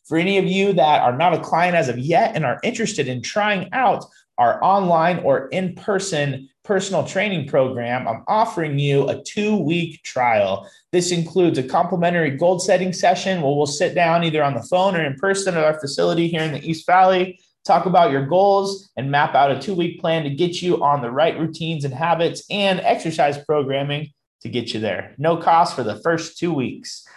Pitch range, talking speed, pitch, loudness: 145-185 Hz, 205 wpm, 165 Hz, -19 LUFS